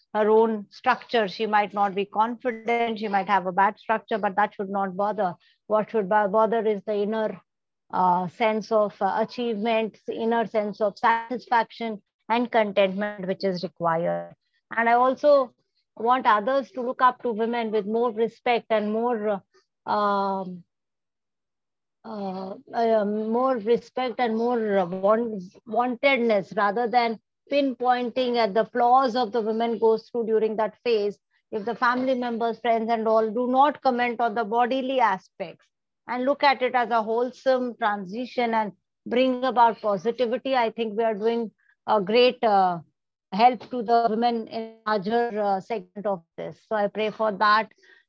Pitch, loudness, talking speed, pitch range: 225 Hz, -24 LUFS, 155 wpm, 210-240 Hz